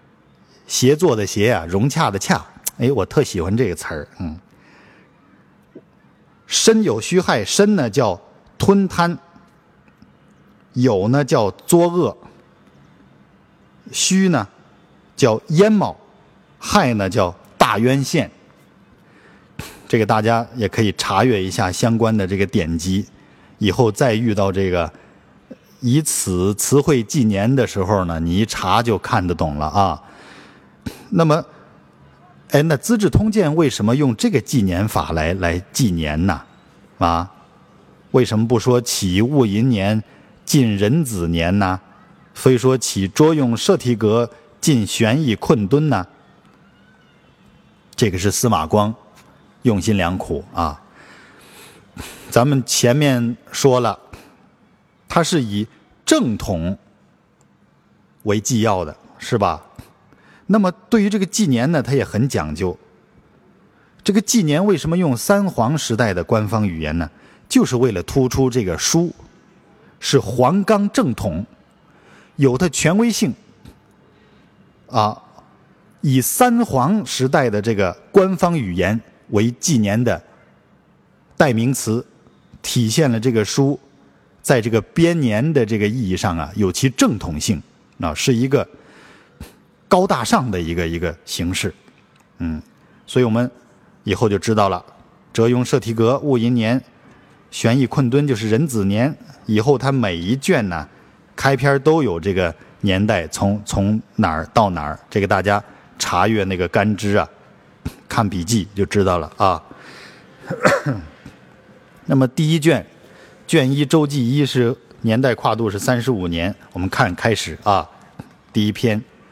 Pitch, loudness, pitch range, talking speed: 115 Hz, -18 LUFS, 100-140 Hz, 190 characters per minute